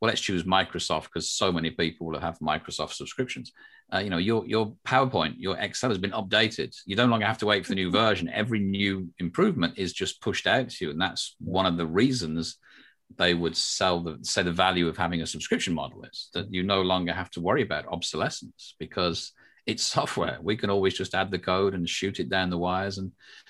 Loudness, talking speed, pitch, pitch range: -27 LUFS, 220 wpm, 95 Hz, 85-100 Hz